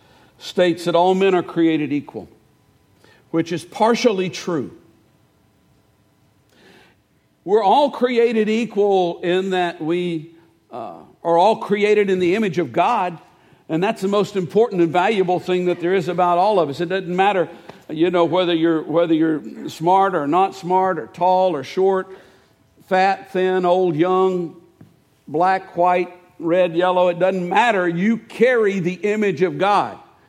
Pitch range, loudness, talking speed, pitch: 170-190 Hz, -18 LUFS, 150 wpm, 180 Hz